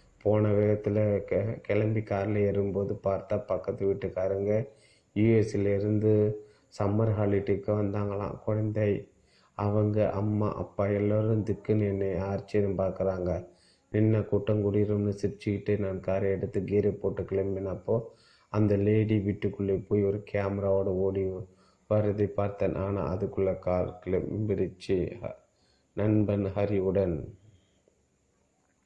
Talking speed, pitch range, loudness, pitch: 95 wpm, 95-105 Hz, -29 LUFS, 100 Hz